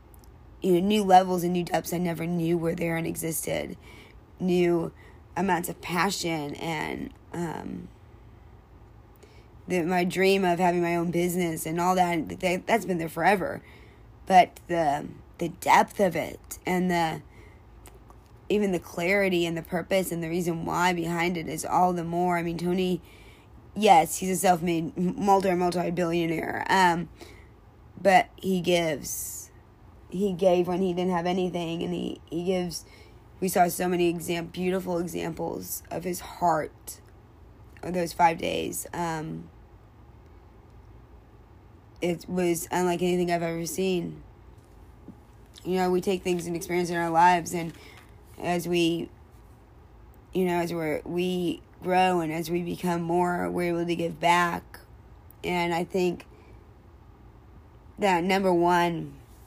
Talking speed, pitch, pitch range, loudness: 140 wpm, 170 Hz, 110-180 Hz, -26 LUFS